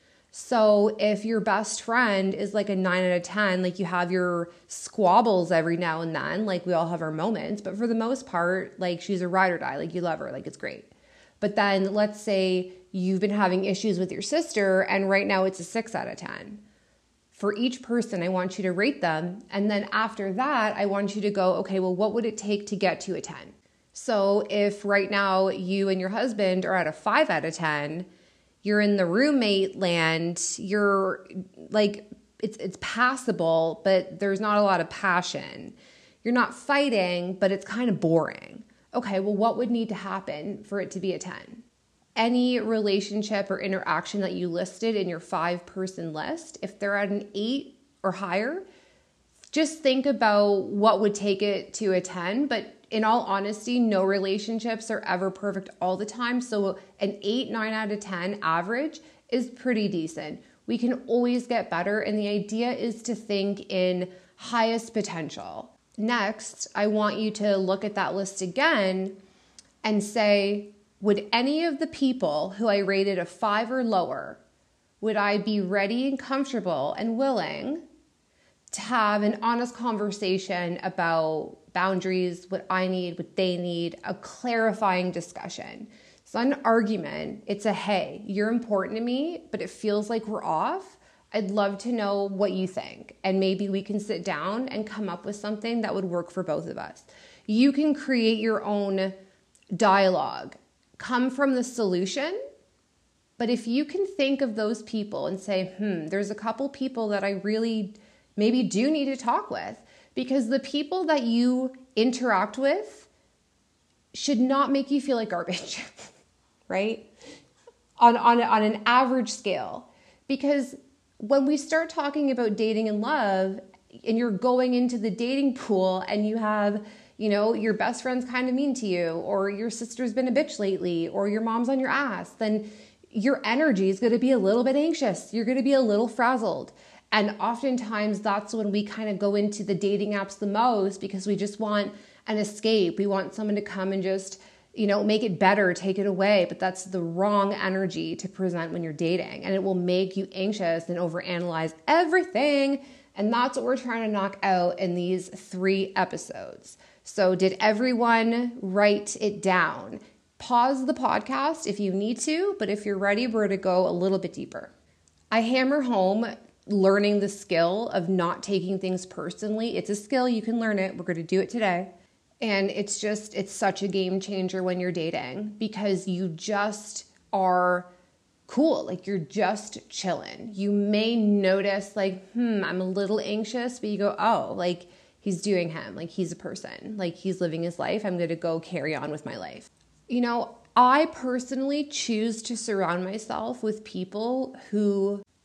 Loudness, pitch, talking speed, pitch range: -26 LUFS, 205 Hz, 185 wpm, 190-230 Hz